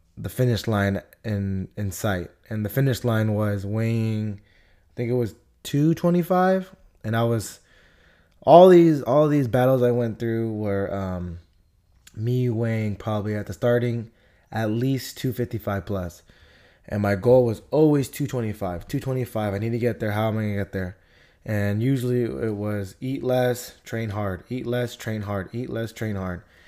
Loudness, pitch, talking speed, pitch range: -23 LUFS, 110 Hz, 165 wpm, 100-125 Hz